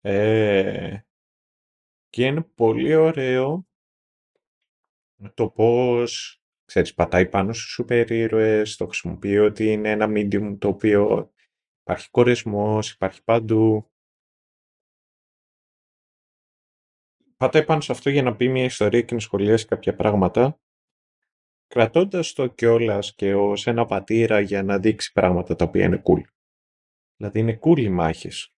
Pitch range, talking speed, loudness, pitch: 100-120 Hz, 125 wpm, -21 LUFS, 110 Hz